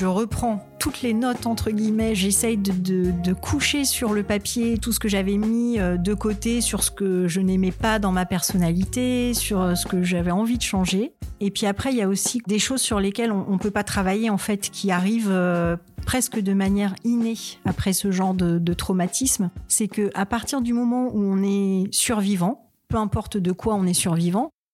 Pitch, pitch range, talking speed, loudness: 205 Hz, 190-230 Hz, 210 wpm, -22 LUFS